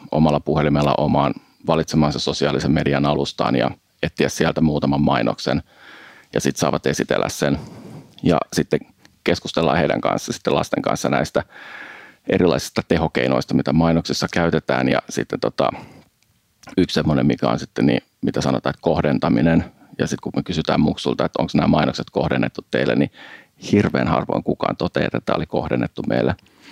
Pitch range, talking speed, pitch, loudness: 65-80 Hz, 150 wpm, 70 Hz, -20 LUFS